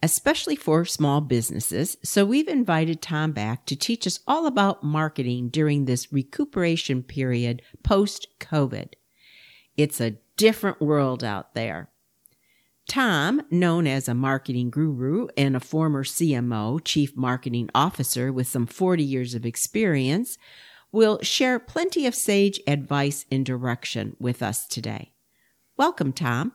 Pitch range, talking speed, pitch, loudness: 125-175 Hz, 135 wpm, 145 Hz, -24 LUFS